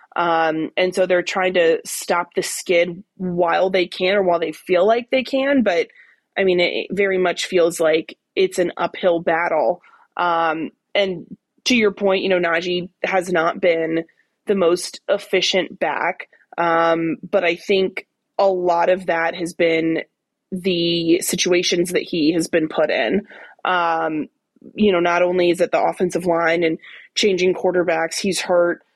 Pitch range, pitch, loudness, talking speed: 170-190 Hz, 180 Hz, -19 LUFS, 165 wpm